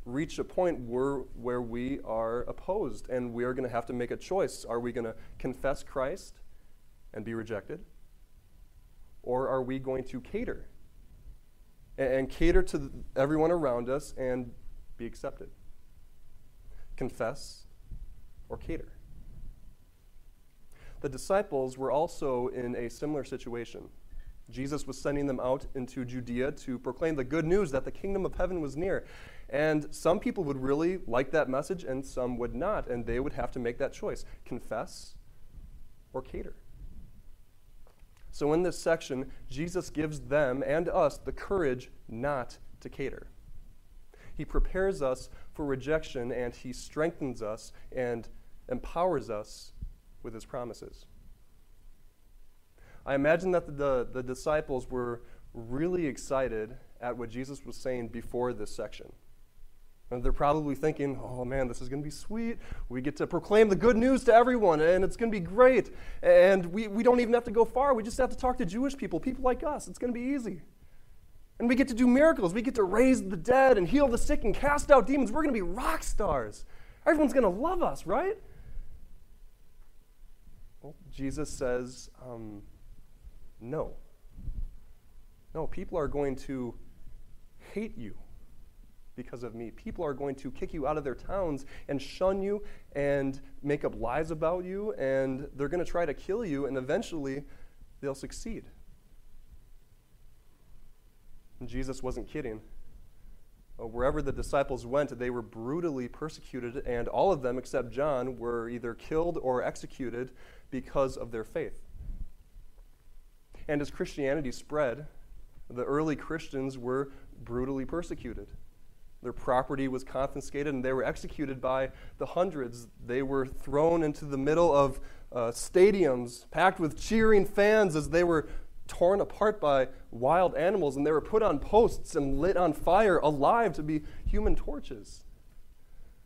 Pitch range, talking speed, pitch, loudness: 125-170 Hz, 155 wpm, 135 Hz, -30 LUFS